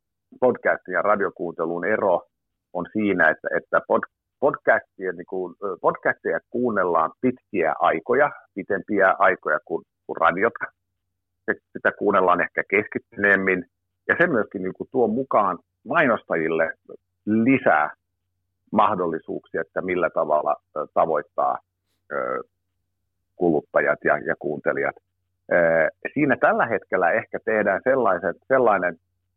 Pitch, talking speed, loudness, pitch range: 95 Hz, 100 wpm, -22 LUFS, 90-95 Hz